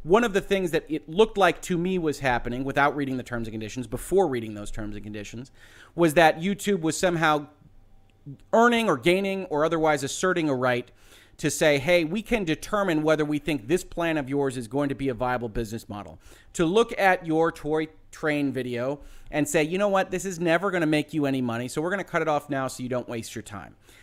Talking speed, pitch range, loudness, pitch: 230 wpm, 125-175 Hz, -25 LUFS, 150 Hz